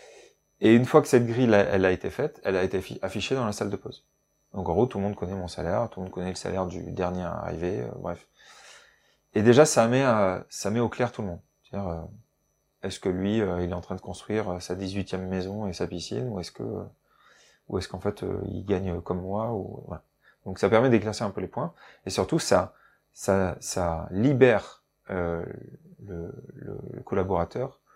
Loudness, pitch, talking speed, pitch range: -27 LUFS, 95 Hz, 220 wpm, 90-115 Hz